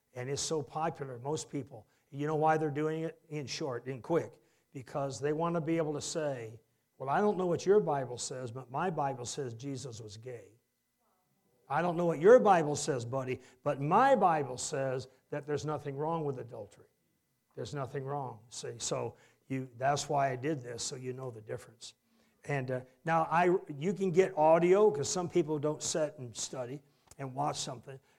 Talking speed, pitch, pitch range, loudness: 195 wpm, 145 Hz, 130-160 Hz, -32 LUFS